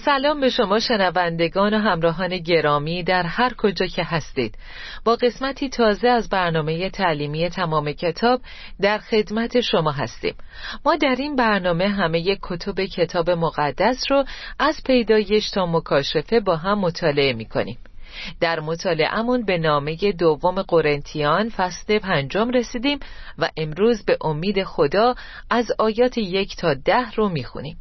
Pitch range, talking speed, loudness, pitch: 165-230 Hz, 135 wpm, -21 LUFS, 195 Hz